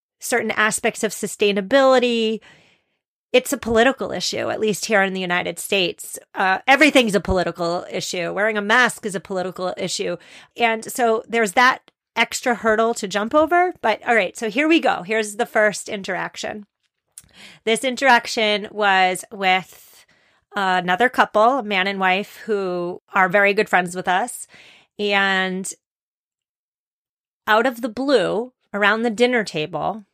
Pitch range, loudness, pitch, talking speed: 190-240 Hz, -19 LUFS, 215 Hz, 145 wpm